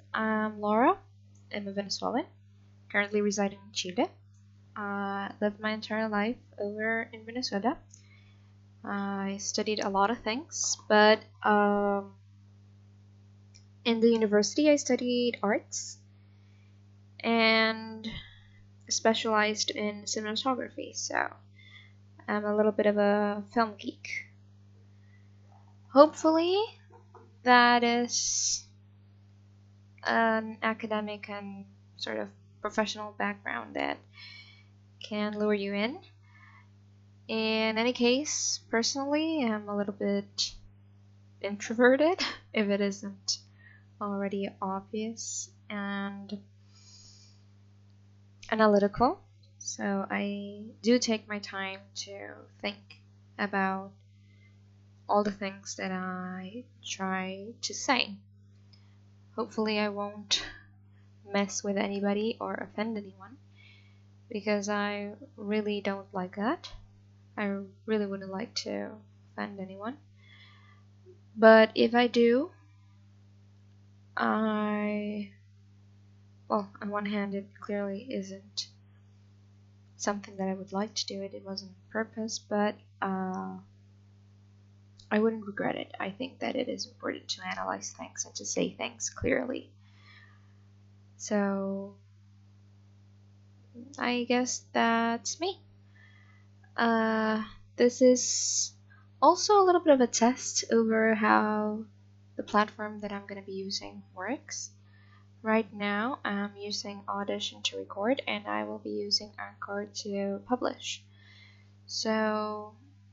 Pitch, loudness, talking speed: 105 Hz, -30 LUFS, 105 wpm